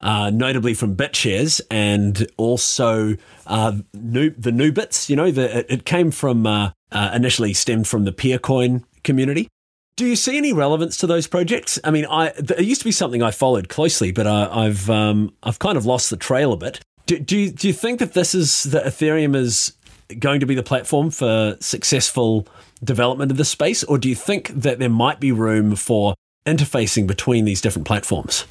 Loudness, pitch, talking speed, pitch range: -19 LUFS, 125 Hz, 200 wpm, 110-150 Hz